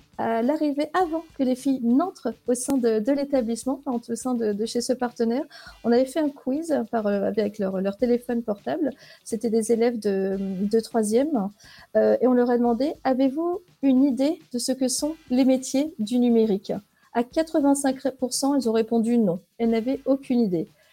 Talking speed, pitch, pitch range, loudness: 180 wpm, 245 Hz, 230-275 Hz, -24 LUFS